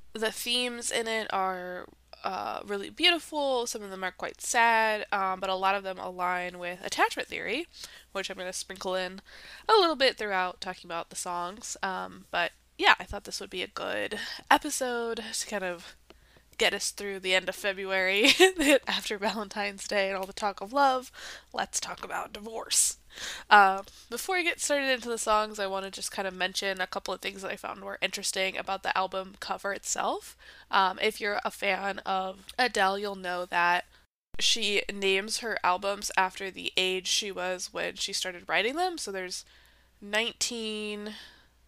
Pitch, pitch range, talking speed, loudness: 200 Hz, 190-225 Hz, 185 wpm, -28 LUFS